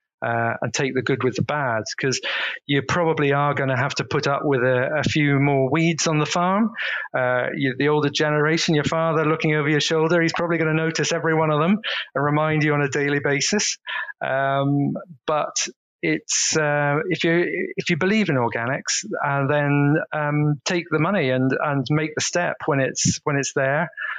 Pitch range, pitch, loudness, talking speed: 140-160 Hz, 150 Hz, -21 LUFS, 200 wpm